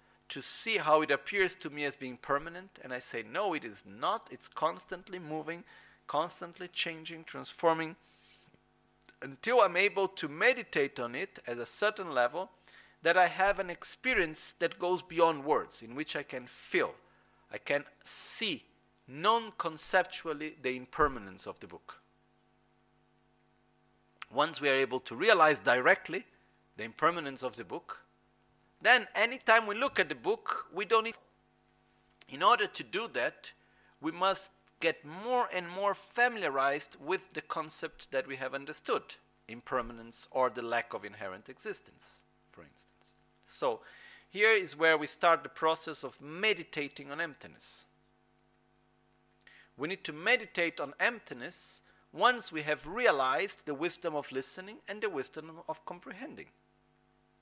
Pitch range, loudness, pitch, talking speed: 145-190 Hz, -32 LUFS, 165 Hz, 145 wpm